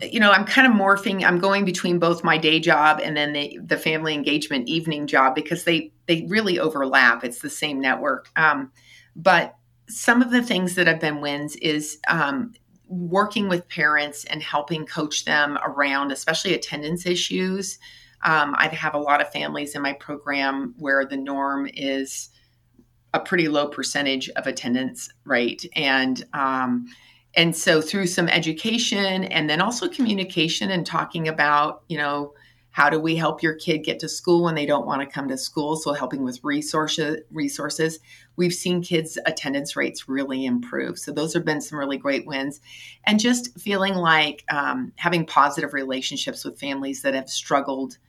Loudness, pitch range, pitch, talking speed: -22 LUFS, 140-175 Hz, 150 Hz, 175 wpm